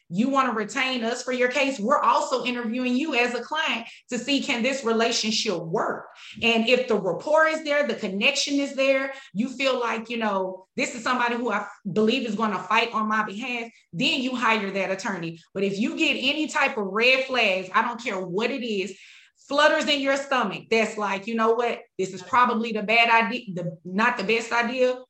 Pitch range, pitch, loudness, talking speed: 215-260 Hz, 235 Hz, -23 LUFS, 215 wpm